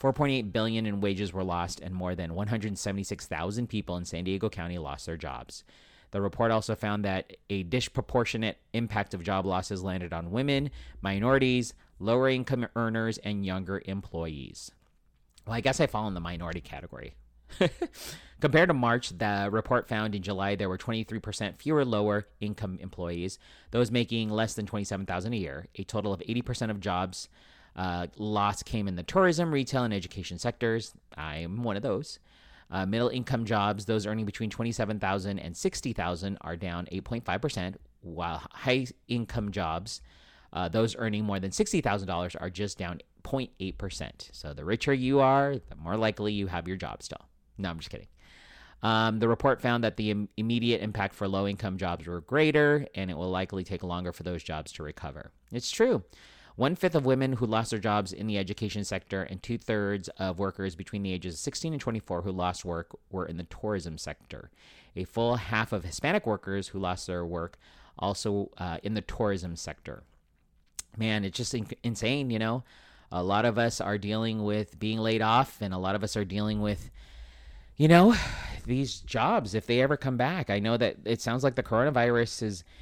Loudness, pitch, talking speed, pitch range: -30 LUFS, 105 Hz, 185 wpm, 90-115 Hz